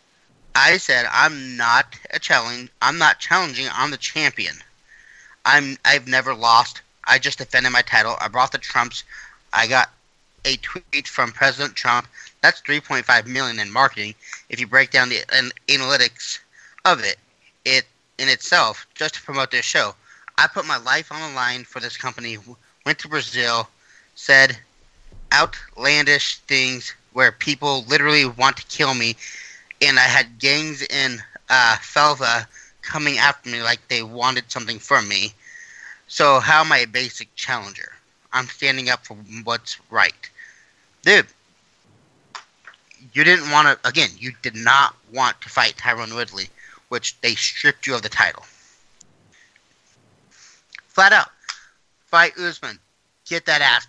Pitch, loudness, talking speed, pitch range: 130 Hz, -18 LUFS, 150 wpm, 120-145 Hz